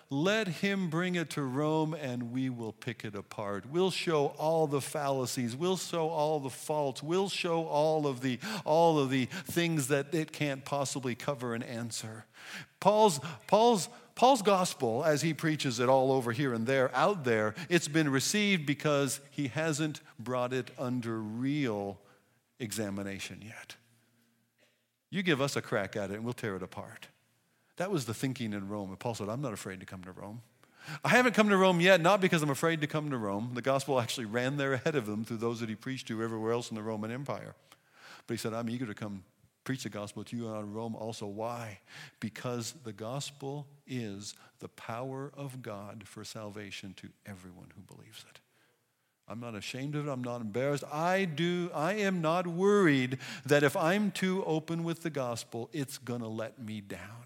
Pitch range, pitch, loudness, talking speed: 115-155 Hz, 130 Hz, -32 LUFS, 195 wpm